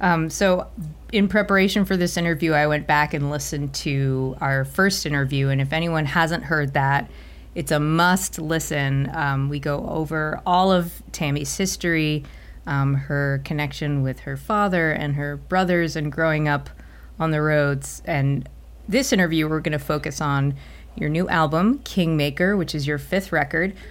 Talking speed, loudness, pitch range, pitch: 165 wpm, -22 LUFS, 145-175 Hz, 155 Hz